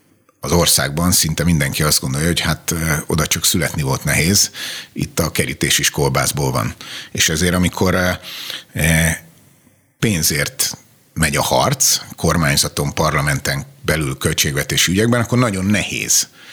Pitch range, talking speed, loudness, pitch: 80-105 Hz, 125 wpm, -16 LUFS, 90 Hz